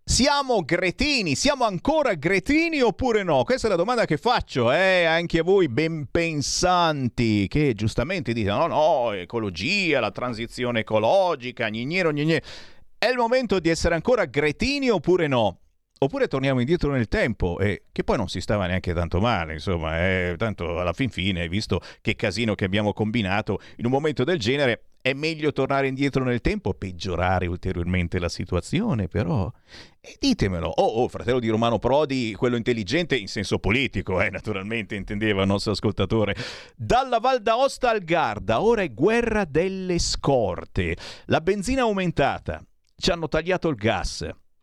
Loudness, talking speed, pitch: -23 LUFS, 160 wpm, 125 Hz